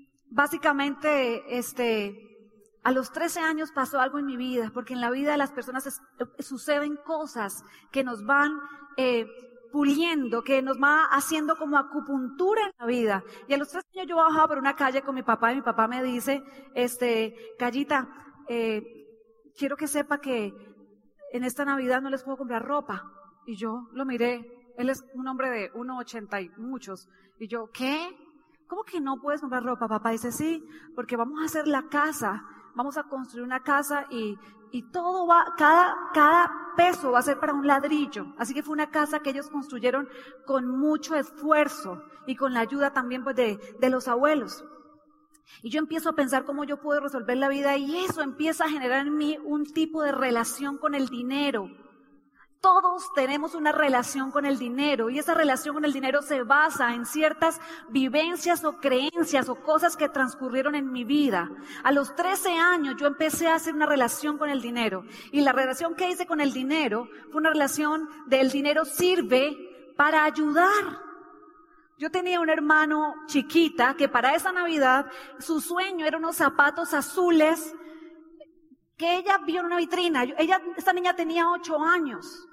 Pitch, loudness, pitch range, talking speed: 285 Hz, -26 LUFS, 255-315 Hz, 180 wpm